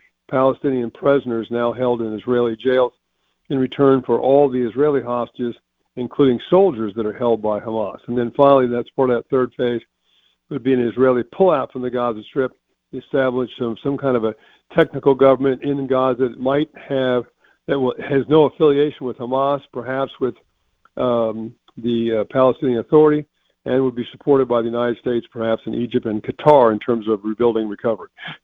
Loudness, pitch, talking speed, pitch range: -19 LUFS, 125 Hz, 175 wpm, 120-135 Hz